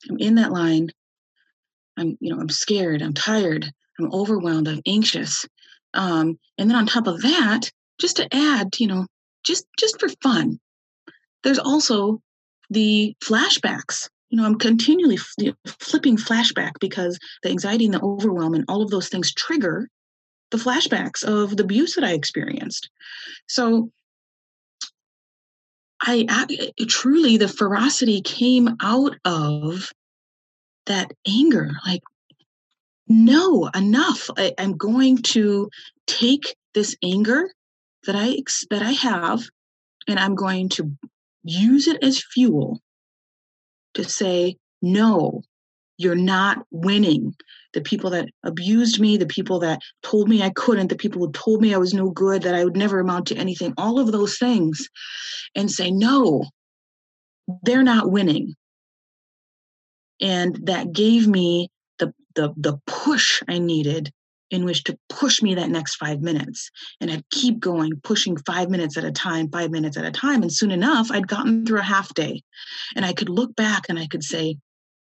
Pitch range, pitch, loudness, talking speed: 180-240 Hz, 205 Hz, -20 LUFS, 150 wpm